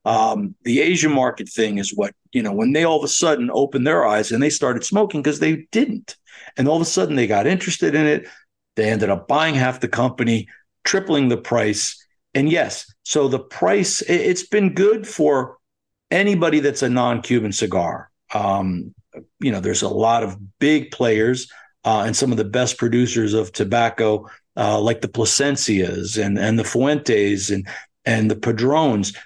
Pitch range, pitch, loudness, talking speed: 110-160 Hz, 125 Hz, -19 LUFS, 185 wpm